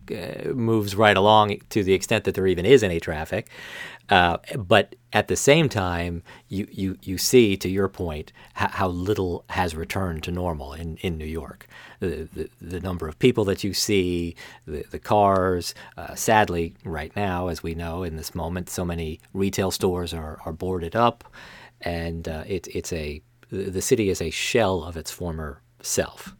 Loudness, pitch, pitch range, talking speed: -24 LUFS, 90 Hz, 85-100 Hz, 185 wpm